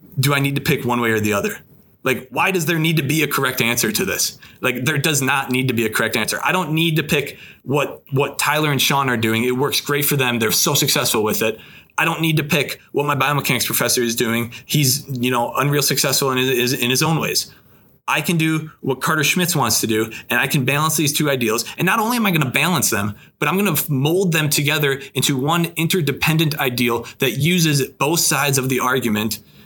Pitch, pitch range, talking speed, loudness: 140 Hz, 125-155 Hz, 245 wpm, -18 LUFS